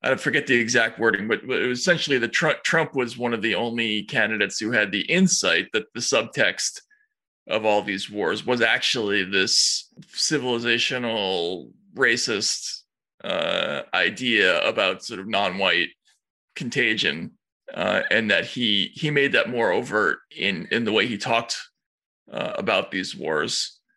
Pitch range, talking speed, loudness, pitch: 115-165 Hz, 150 wpm, -22 LUFS, 125 Hz